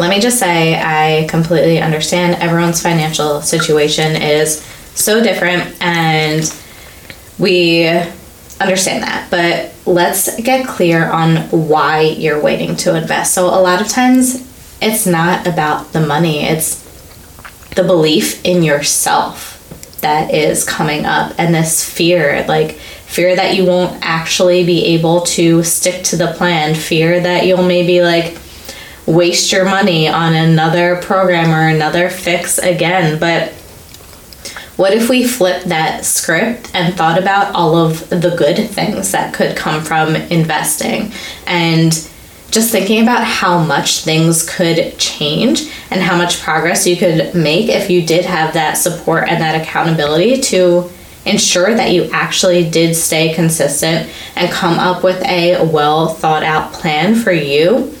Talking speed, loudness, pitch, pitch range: 145 wpm, -12 LUFS, 170 Hz, 160-180 Hz